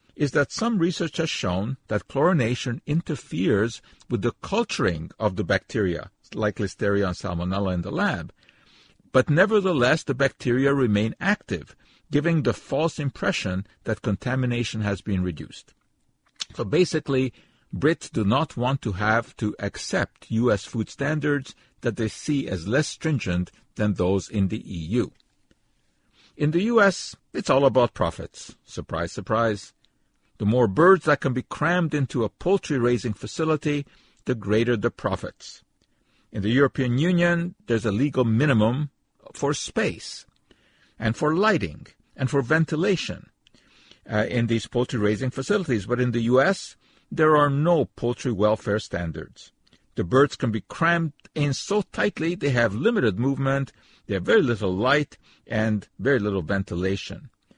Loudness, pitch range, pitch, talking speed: -24 LUFS, 105-145 Hz, 120 Hz, 145 wpm